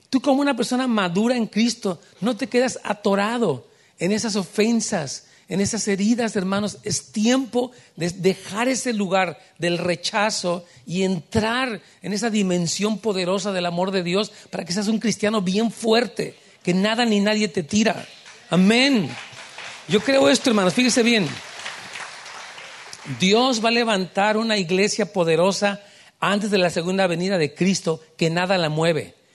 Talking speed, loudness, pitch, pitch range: 150 wpm, -21 LUFS, 205 Hz, 185-225 Hz